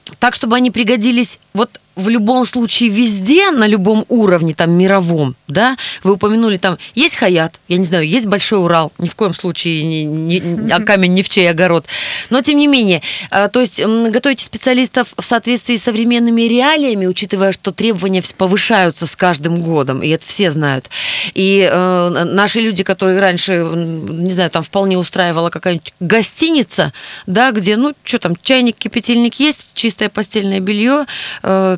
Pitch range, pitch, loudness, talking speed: 175-235 Hz, 200 Hz, -13 LUFS, 165 wpm